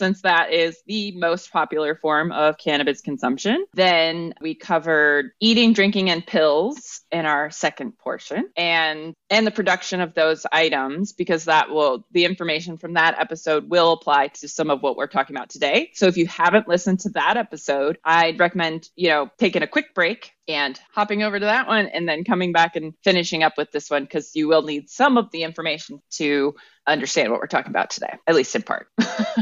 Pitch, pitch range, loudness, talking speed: 165 Hz, 155-190 Hz, -20 LUFS, 200 wpm